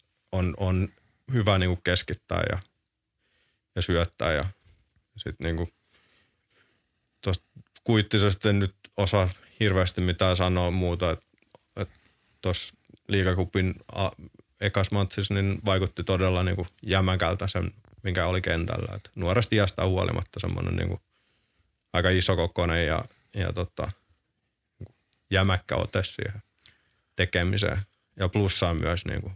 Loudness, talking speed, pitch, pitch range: -27 LUFS, 110 wpm, 95 Hz, 90-105 Hz